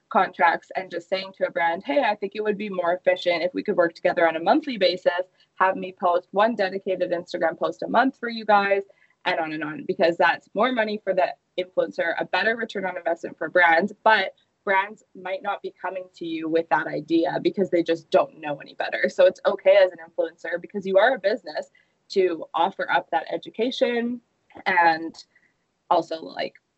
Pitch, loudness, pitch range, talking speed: 185 Hz, -23 LUFS, 170-215 Hz, 205 wpm